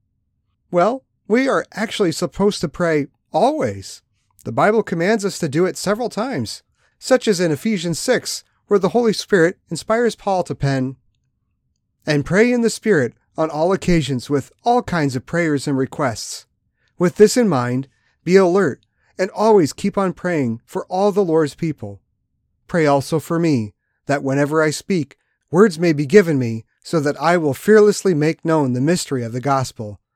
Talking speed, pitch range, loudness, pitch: 170 wpm, 140-205 Hz, -18 LUFS, 170 Hz